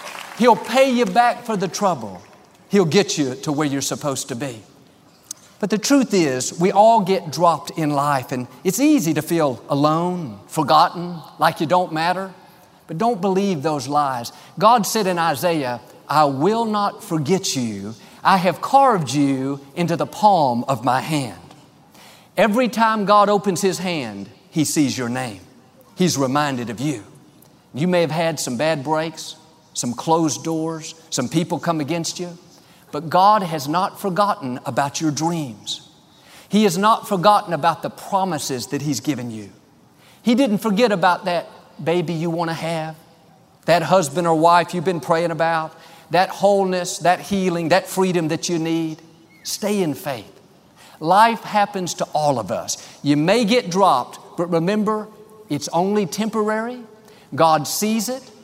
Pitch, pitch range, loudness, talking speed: 170 Hz, 150-195 Hz, -19 LUFS, 160 wpm